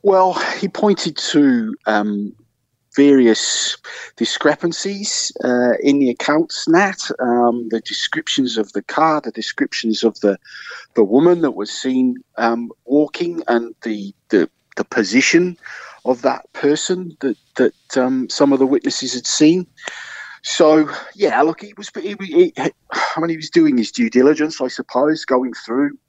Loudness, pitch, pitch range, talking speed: -17 LUFS, 145 Hz, 120-180 Hz, 150 wpm